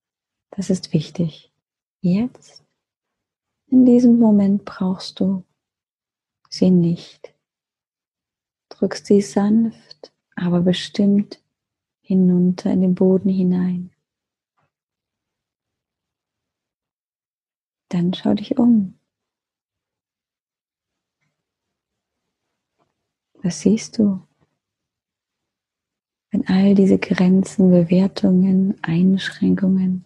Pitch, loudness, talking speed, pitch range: 190 Hz, -18 LUFS, 70 wpm, 180-205 Hz